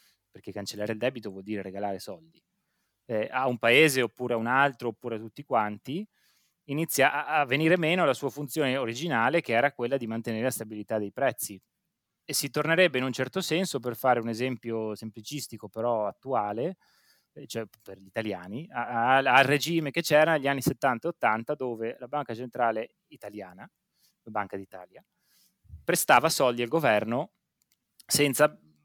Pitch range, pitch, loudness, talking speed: 110-150 Hz, 125 Hz, -27 LUFS, 155 wpm